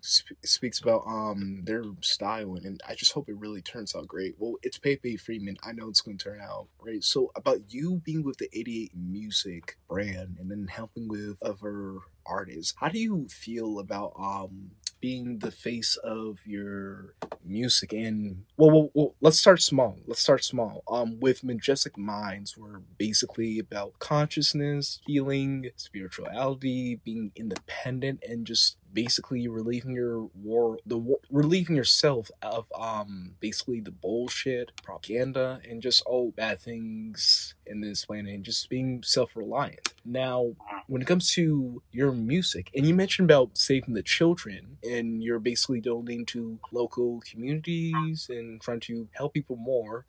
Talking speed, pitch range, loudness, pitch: 155 wpm, 105-130 Hz, -28 LUFS, 115 Hz